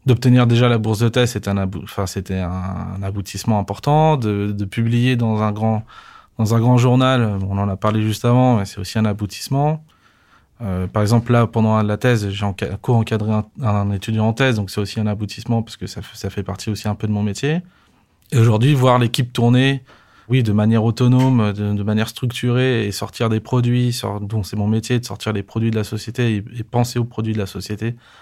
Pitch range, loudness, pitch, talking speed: 105-120 Hz, -19 LUFS, 110 Hz, 220 wpm